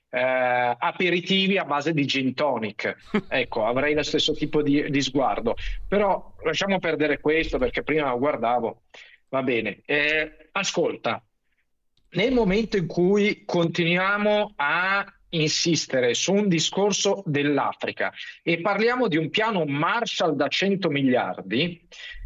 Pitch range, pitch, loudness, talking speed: 145-195 Hz, 165 Hz, -23 LUFS, 125 wpm